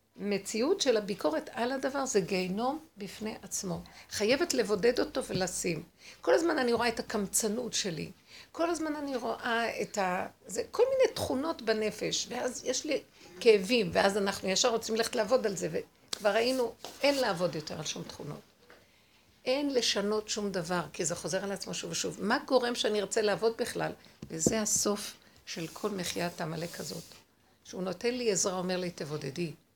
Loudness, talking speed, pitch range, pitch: -31 LUFS, 165 wpm, 185-245 Hz, 215 Hz